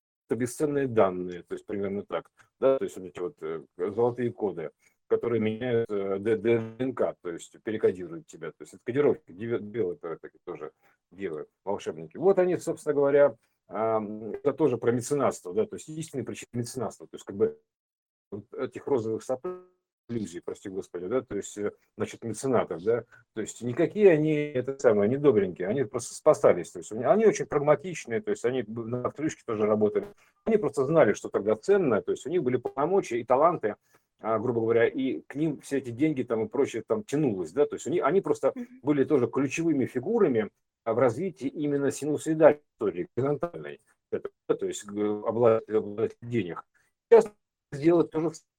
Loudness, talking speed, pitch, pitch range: -28 LUFS, 170 wpm, 140 Hz, 115-180 Hz